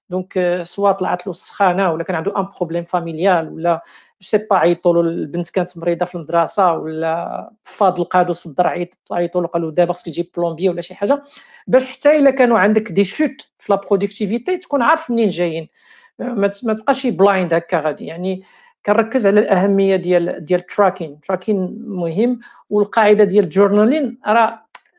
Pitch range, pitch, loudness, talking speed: 175-220 Hz, 190 Hz, -17 LUFS, 160 wpm